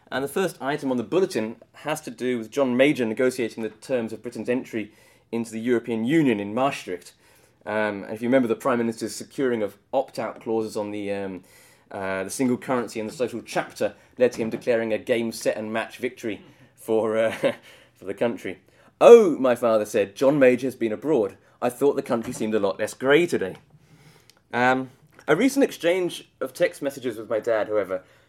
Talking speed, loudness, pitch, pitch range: 200 wpm, -24 LUFS, 120 Hz, 110-135 Hz